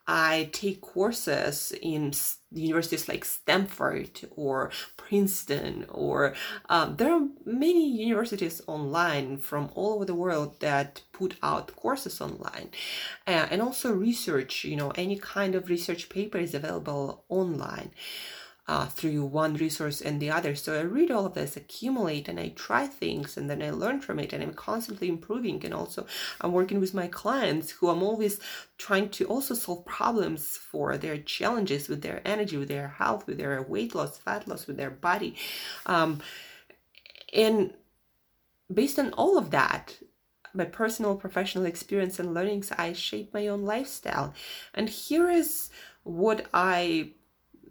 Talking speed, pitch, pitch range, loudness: 155 wpm, 185 Hz, 160-215 Hz, -29 LUFS